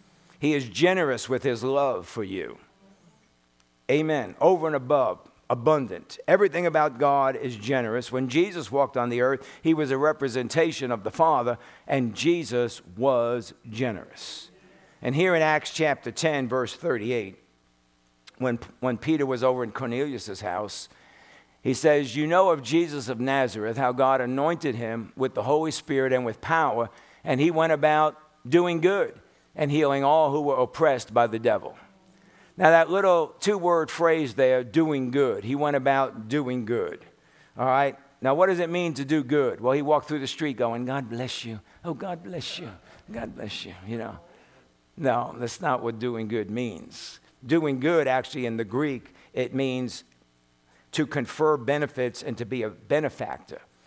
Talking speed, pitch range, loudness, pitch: 170 wpm, 120-155 Hz, -25 LUFS, 135 Hz